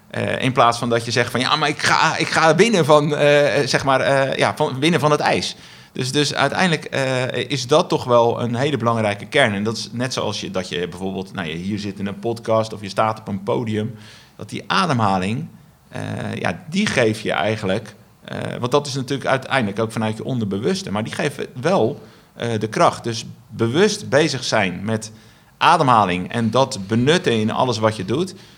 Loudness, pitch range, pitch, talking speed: -19 LUFS, 110-145 Hz, 120 Hz, 205 wpm